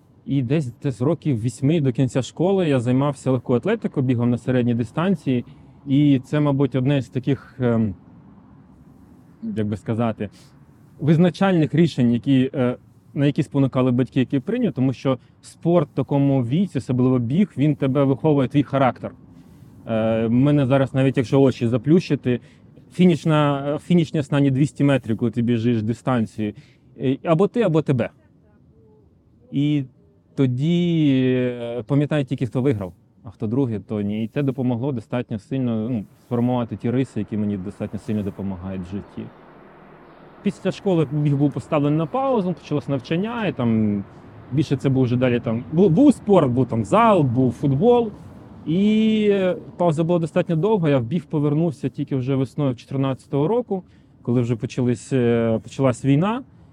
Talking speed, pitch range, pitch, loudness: 145 wpm, 120-150 Hz, 135 Hz, -21 LUFS